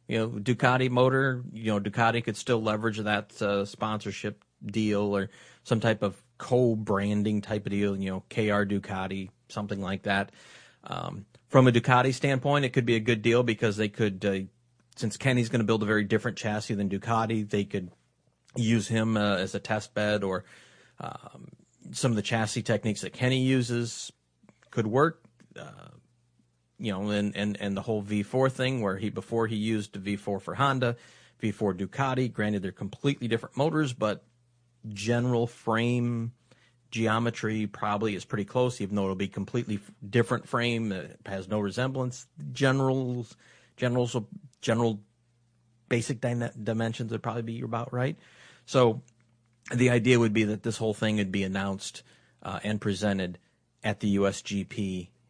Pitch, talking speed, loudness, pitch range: 110 Hz, 160 wpm, -28 LUFS, 100-120 Hz